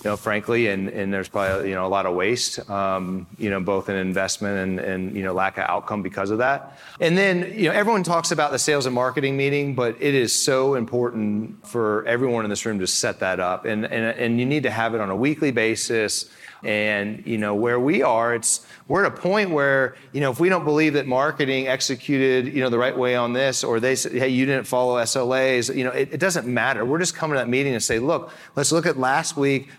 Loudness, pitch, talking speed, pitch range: -22 LUFS, 125 Hz, 250 wpm, 105-140 Hz